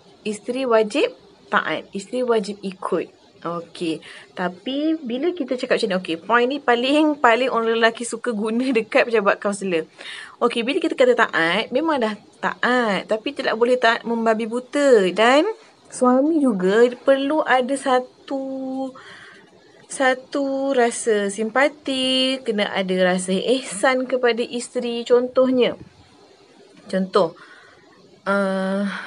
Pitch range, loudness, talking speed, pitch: 210-265 Hz, -20 LUFS, 120 wpm, 240 Hz